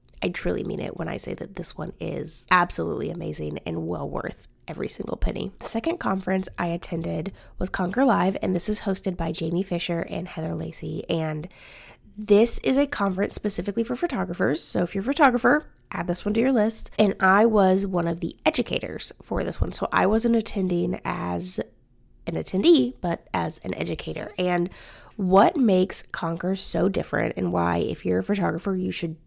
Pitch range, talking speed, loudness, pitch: 170-210 Hz, 185 wpm, -25 LUFS, 190 Hz